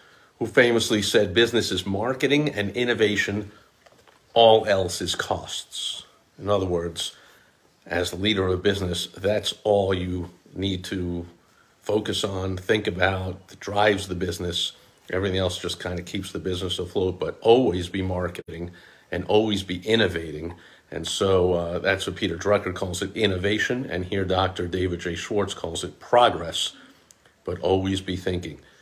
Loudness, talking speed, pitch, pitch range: -24 LUFS, 155 wpm, 95 Hz, 90-105 Hz